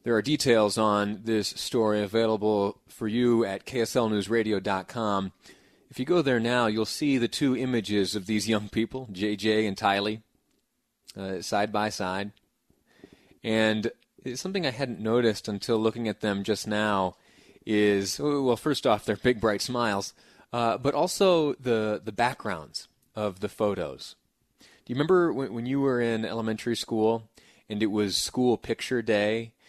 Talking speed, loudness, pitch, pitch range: 155 wpm, -27 LUFS, 110 Hz, 105-120 Hz